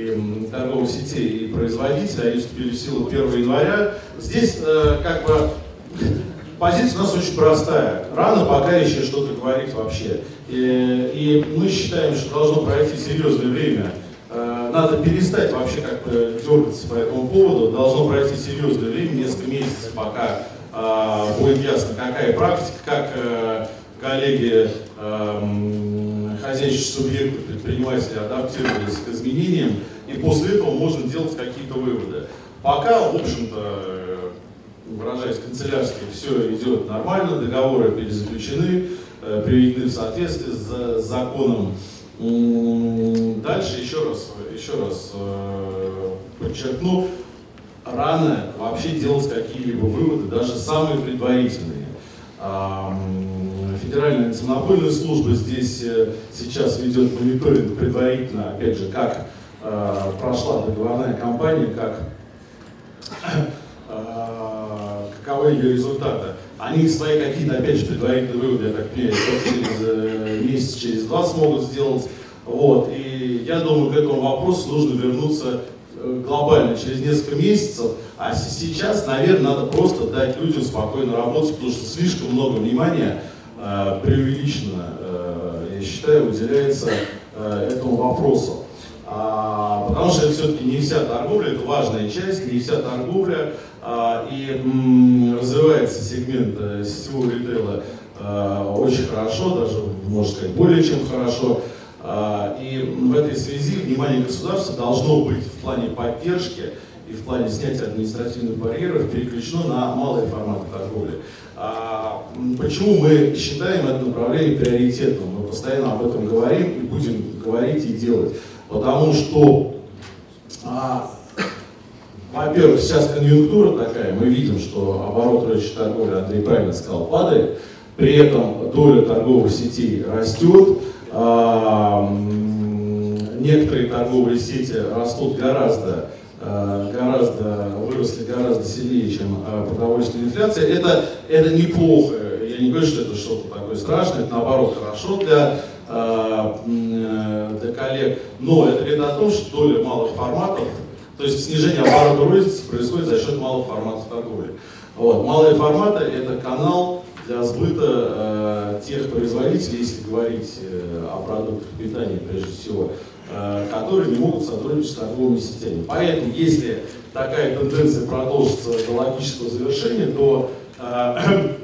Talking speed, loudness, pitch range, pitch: 120 wpm, -20 LUFS, 110-145 Hz, 125 Hz